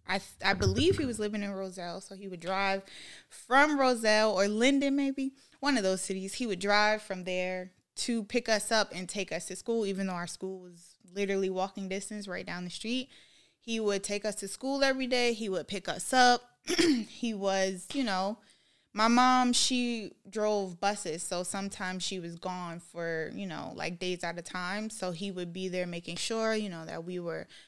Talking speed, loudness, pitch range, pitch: 205 wpm, -31 LUFS, 185-230 Hz, 200 Hz